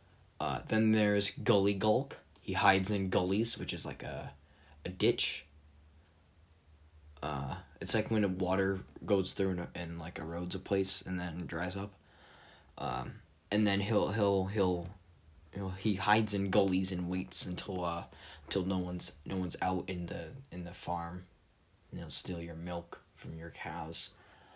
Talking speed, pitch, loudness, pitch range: 165 wpm, 90 Hz, -32 LUFS, 85-100 Hz